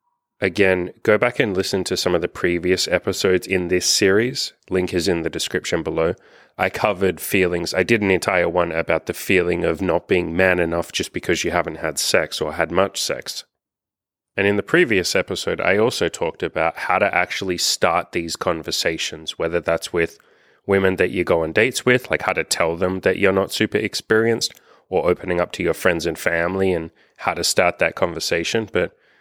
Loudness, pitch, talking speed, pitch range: -20 LUFS, 95 Hz, 195 wpm, 90-100 Hz